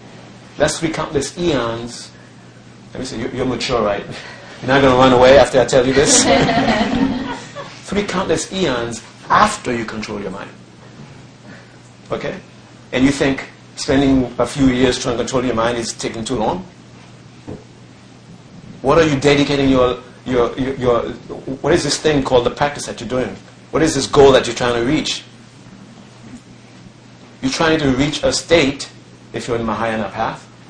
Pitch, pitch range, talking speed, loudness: 125 Hz, 110-145 Hz, 165 wpm, -16 LUFS